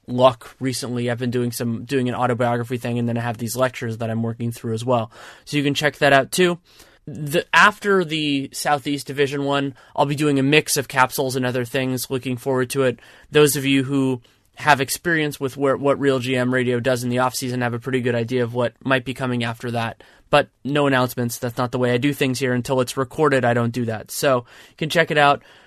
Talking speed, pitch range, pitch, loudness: 240 wpm, 120-140 Hz, 130 Hz, -20 LUFS